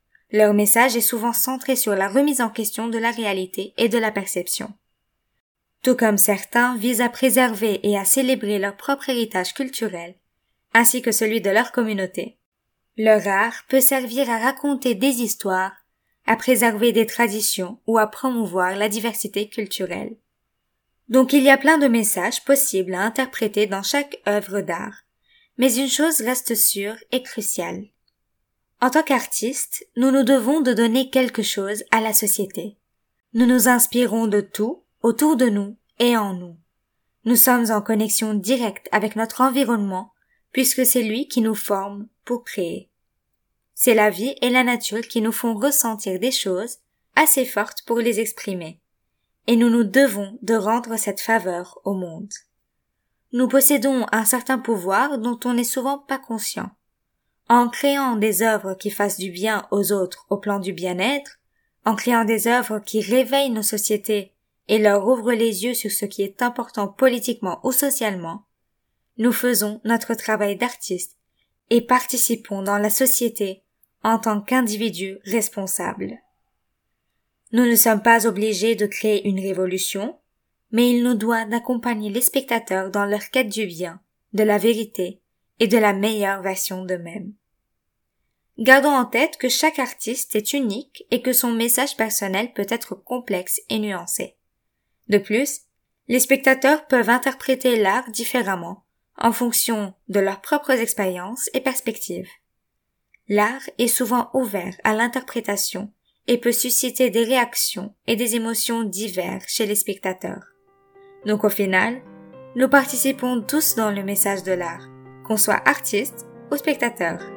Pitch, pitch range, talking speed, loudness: 230 Hz, 205-250 Hz, 155 wpm, -20 LUFS